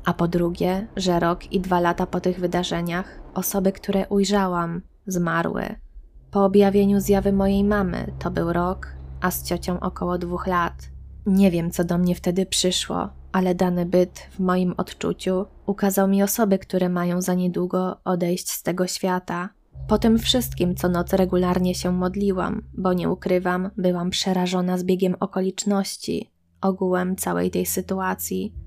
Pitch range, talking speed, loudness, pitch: 175-195 Hz, 150 wpm, -23 LUFS, 180 Hz